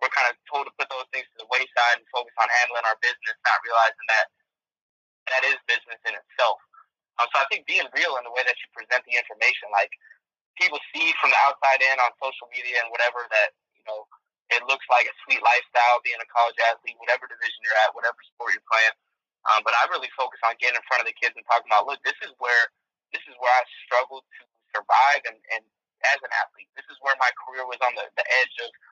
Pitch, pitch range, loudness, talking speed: 125 Hz, 120-150 Hz, -23 LUFS, 235 wpm